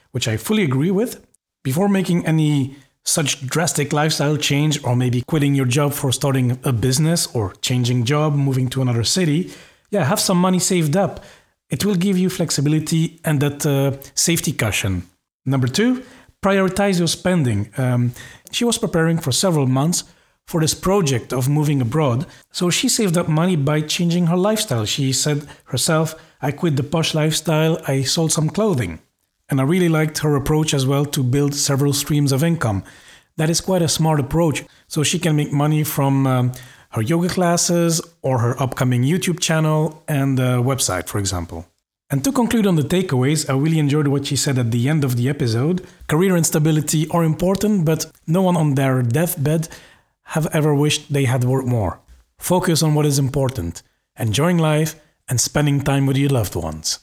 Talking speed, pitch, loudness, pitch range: 180 wpm, 150 Hz, -19 LUFS, 130-165 Hz